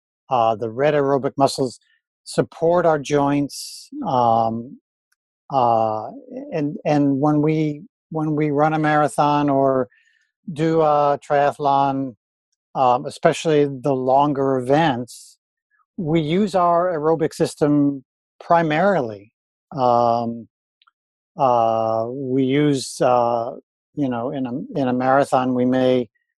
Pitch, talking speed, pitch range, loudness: 140 Hz, 110 wpm, 125-155 Hz, -19 LUFS